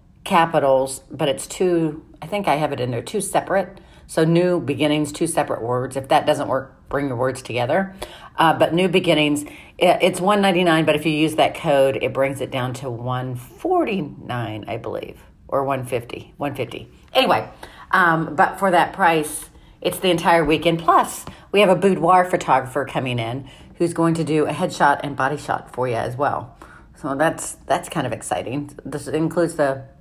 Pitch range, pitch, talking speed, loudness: 135-175 Hz, 155 Hz, 180 wpm, -20 LUFS